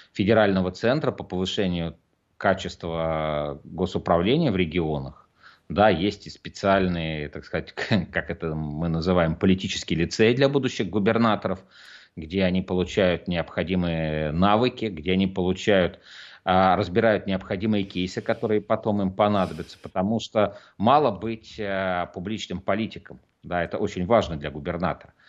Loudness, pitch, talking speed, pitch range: -24 LUFS, 95 Hz, 120 wpm, 85-105 Hz